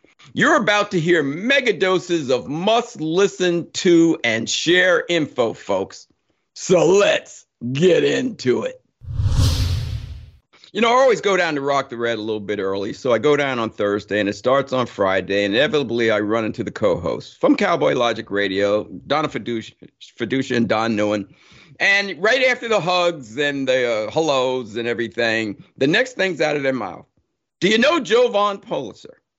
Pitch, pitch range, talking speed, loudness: 135 Hz, 110-180 Hz, 175 wpm, -19 LUFS